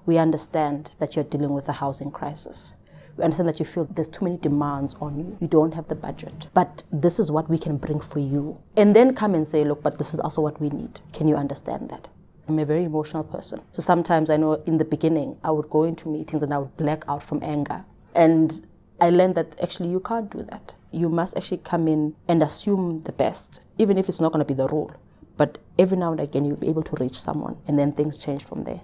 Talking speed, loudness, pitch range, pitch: 250 wpm, -23 LUFS, 150-170 Hz, 155 Hz